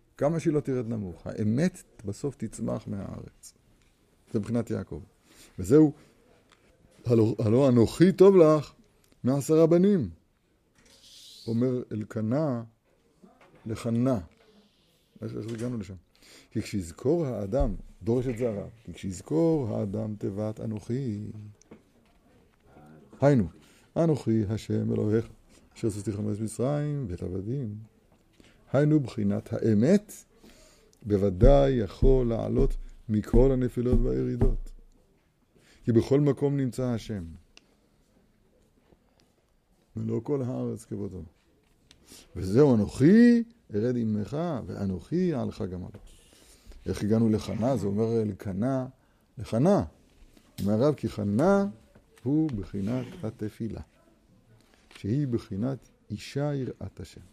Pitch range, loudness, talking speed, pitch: 105-130 Hz, -27 LUFS, 95 wpm, 115 Hz